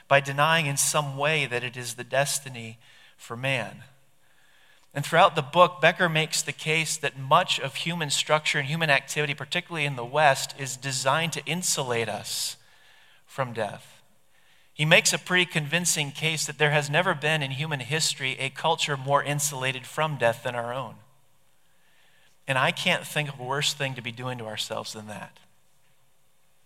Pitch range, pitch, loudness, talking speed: 135-160 Hz, 145 Hz, -25 LUFS, 175 wpm